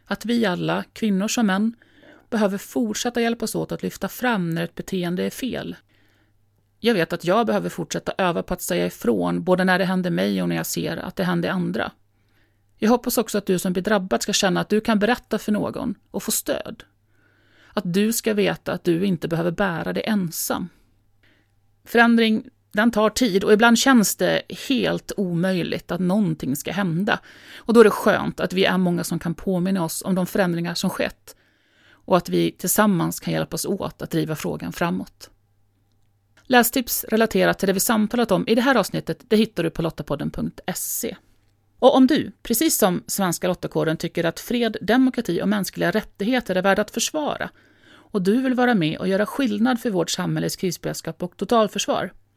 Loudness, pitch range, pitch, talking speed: -22 LUFS, 165-220 Hz, 190 Hz, 185 wpm